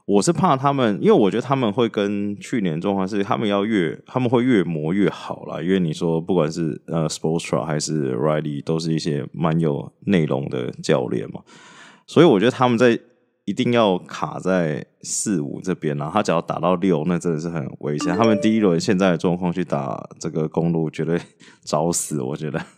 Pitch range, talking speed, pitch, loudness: 80-105 Hz, 320 characters per minute, 90 Hz, -21 LUFS